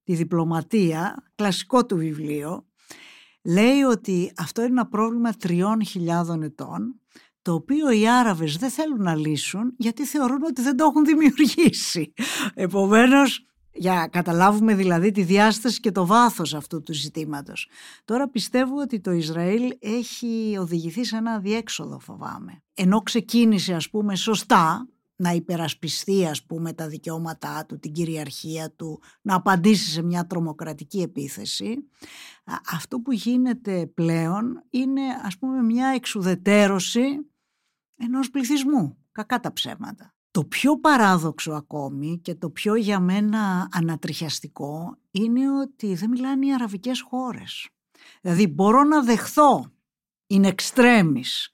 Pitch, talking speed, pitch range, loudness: 205 Hz, 130 wpm, 170-245 Hz, -22 LUFS